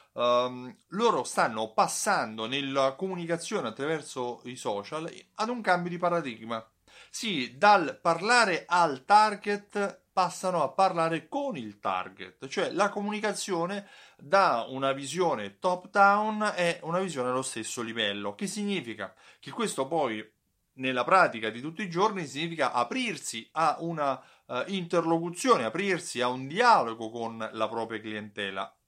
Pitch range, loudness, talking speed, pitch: 120-195 Hz, -28 LUFS, 135 wpm, 165 Hz